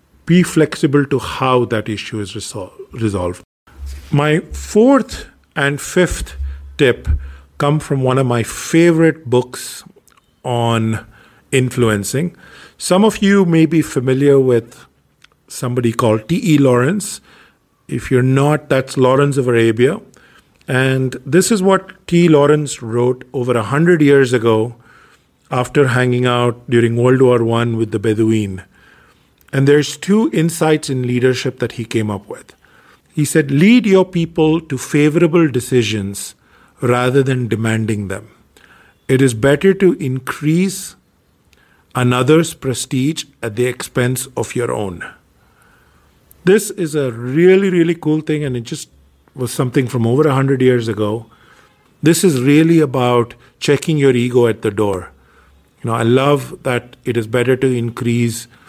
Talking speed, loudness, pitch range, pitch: 140 wpm, -15 LUFS, 115-150 Hz, 130 Hz